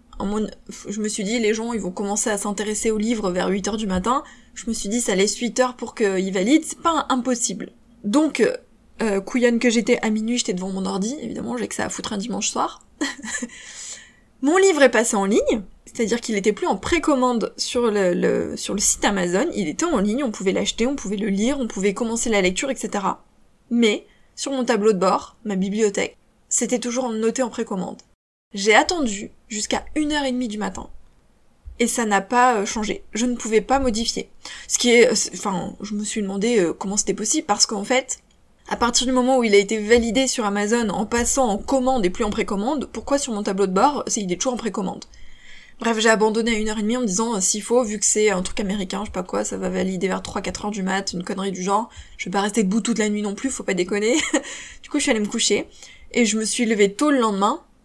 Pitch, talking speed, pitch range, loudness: 220 Hz, 240 wpm, 205-245 Hz, -21 LUFS